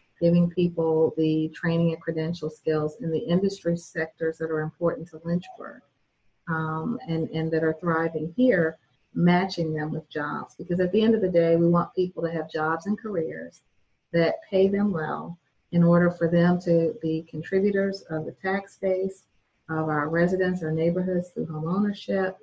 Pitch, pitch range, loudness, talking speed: 170 Hz, 160-180 Hz, -25 LUFS, 175 wpm